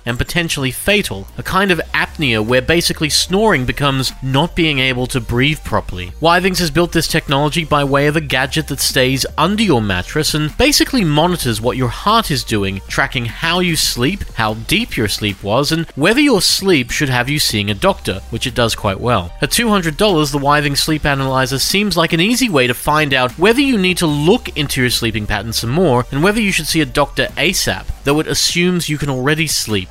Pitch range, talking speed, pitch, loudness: 120-170 Hz, 210 wpm, 145 Hz, -15 LUFS